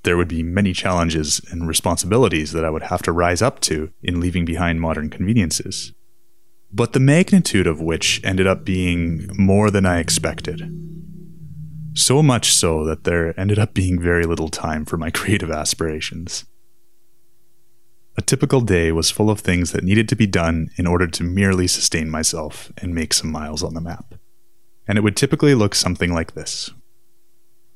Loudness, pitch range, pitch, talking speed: -18 LUFS, 85-115 Hz, 90 Hz, 175 wpm